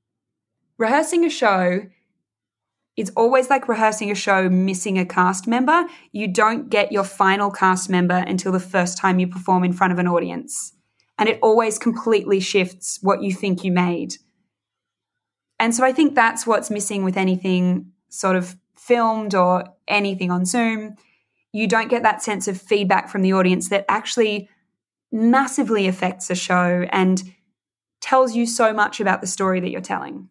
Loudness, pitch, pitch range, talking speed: -19 LUFS, 195 Hz, 185-220 Hz, 165 wpm